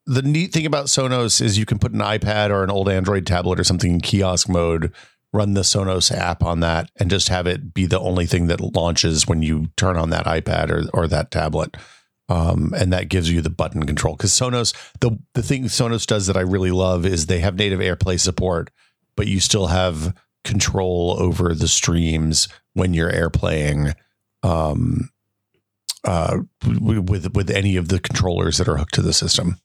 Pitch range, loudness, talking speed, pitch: 85-105 Hz, -19 LUFS, 195 wpm, 95 Hz